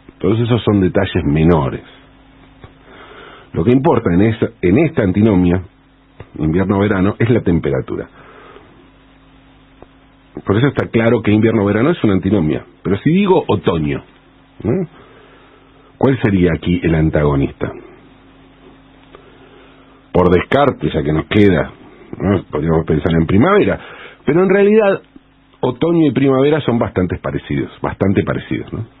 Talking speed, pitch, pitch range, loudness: 120 wpm, 110 Hz, 90-135 Hz, -15 LUFS